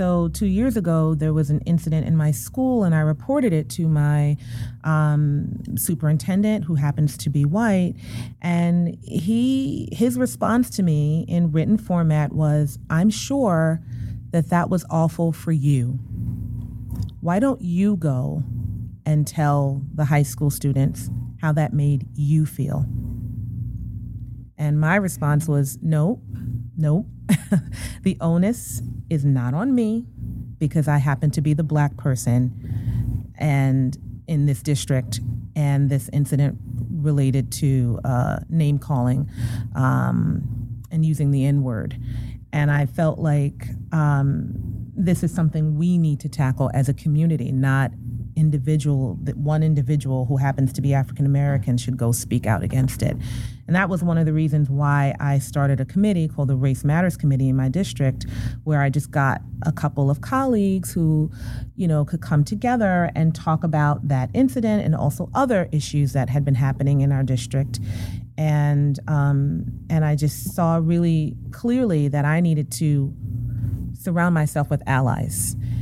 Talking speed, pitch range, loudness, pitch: 155 wpm, 125-160 Hz, -21 LUFS, 145 Hz